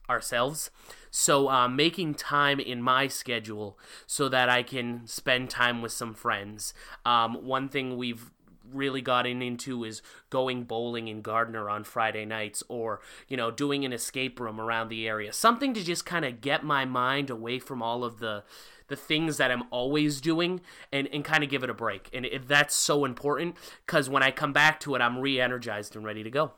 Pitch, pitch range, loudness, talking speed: 125 Hz, 115-140 Hz, -28 LUFS, 195 wpm